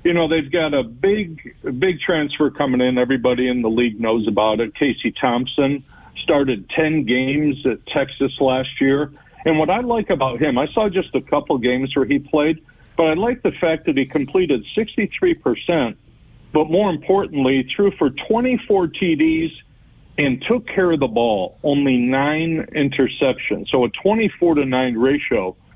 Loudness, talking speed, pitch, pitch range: -19 LUFS, 170 wpm, 145 Hz, 130-170 Hz